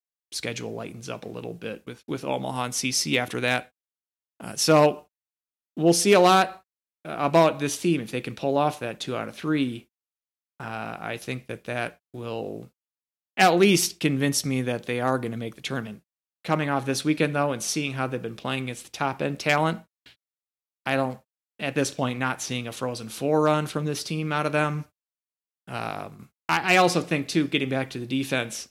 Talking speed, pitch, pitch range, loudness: 195 wpm, 135 Hz, 115-150 Hz, -25 LUFS